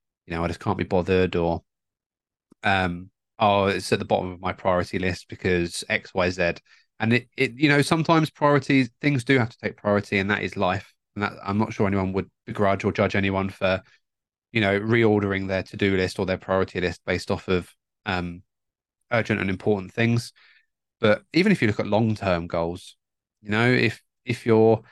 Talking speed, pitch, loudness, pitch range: 195 wpm, 100 Hz, -24 LUFS, 90-115 Hz